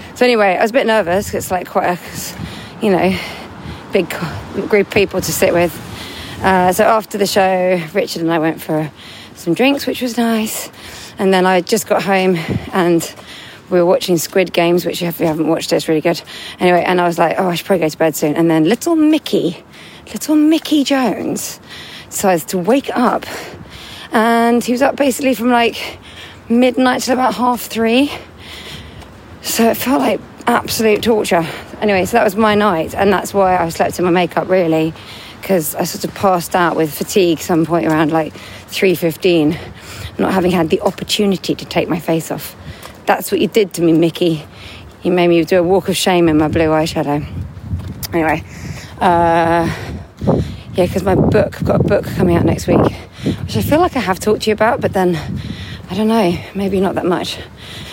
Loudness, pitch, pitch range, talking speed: -15 LUFS, 180 Hz, 165-215 Hz, 195 wpm